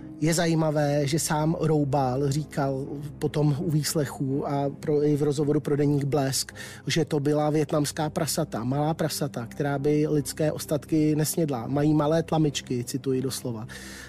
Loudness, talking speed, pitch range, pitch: -26 LUFS, 145 wpm, 140-155 Hz, 150 Hz